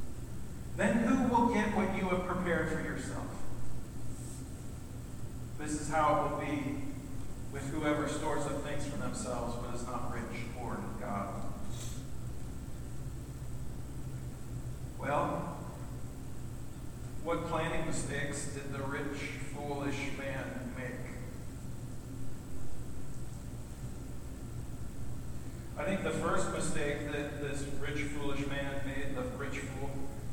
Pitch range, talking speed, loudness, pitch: 125-150 Hz, 105 wpm, -37 LUFS, 140 Hz